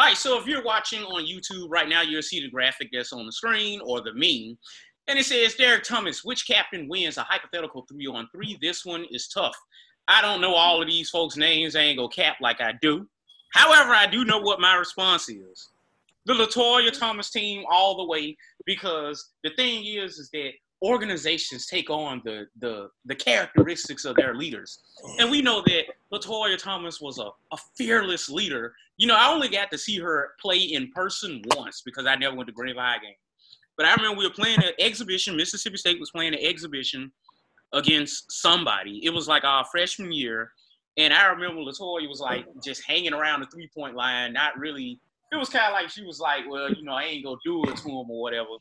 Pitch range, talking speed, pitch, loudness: 140-210 Hz, 210 wpm, 170 Hz, -23 LUFS